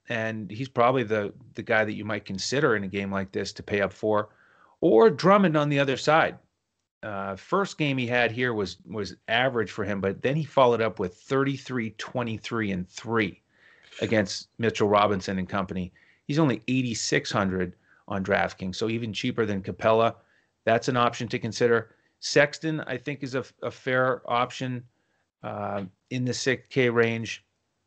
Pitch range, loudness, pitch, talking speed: 105-130 Hz, -26 LUFS, 115 Hz, 170 wpm